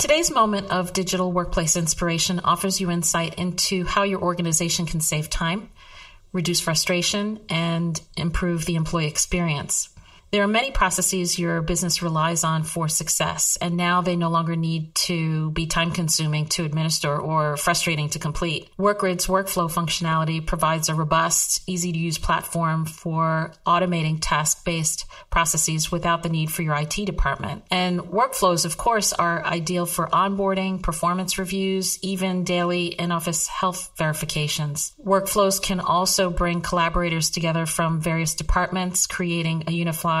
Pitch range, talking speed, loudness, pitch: 165-185 Hz, 150 wpm, -22 LUFS, 170 Hz